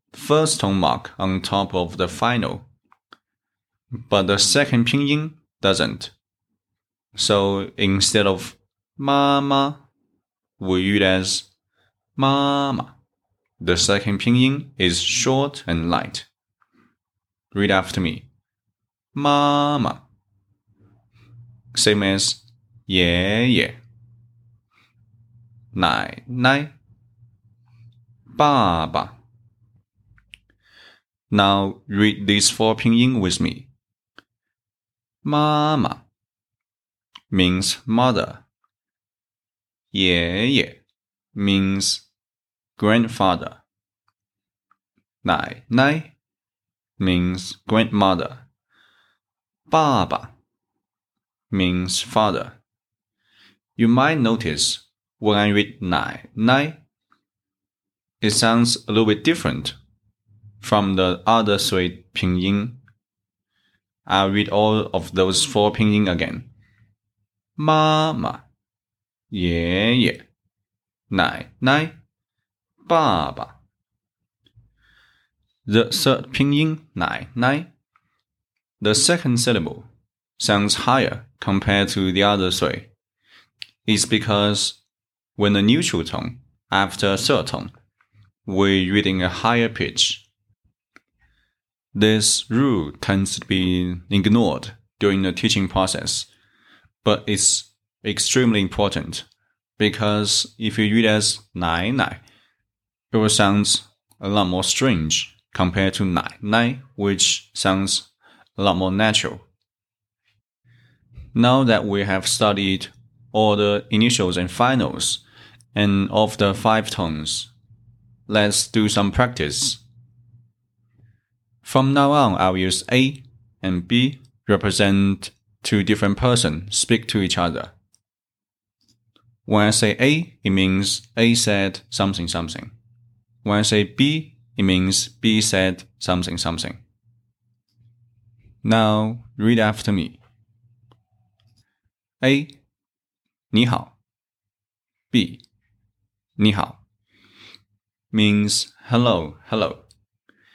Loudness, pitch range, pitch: -19 LUFS, 100-120 Hz, 105 Hz